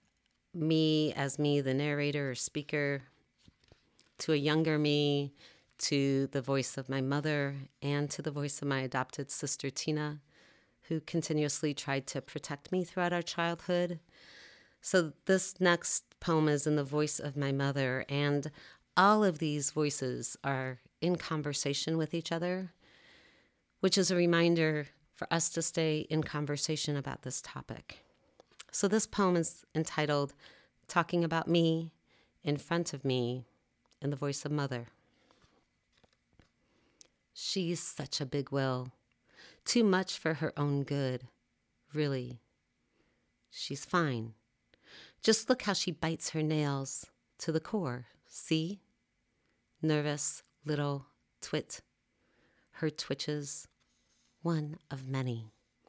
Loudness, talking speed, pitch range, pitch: -33 LUFS, 130 wpm, 140-165 Hz, 150 Hz